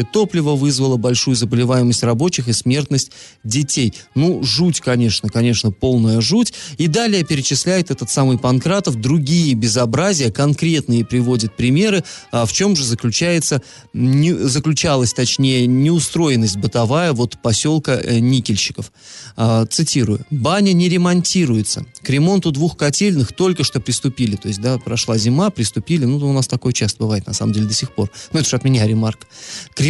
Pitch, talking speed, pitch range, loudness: 130 Hz, 150 wpm, 120-155 Hz, -16 LUFS